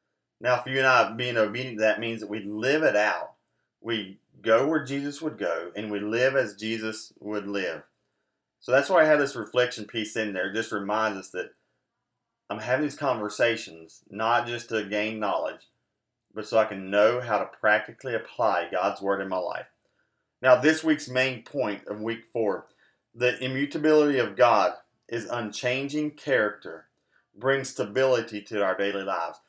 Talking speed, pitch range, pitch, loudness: 175 wpm, 105-130 Hz, 115 Hz, -26 LUFS